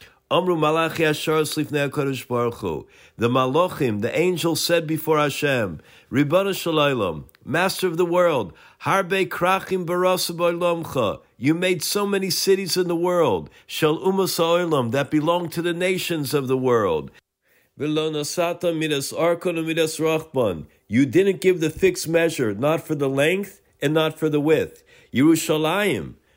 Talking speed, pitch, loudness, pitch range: 115 wpm, 165 Hz, -22 LUFS, 150-180 Hz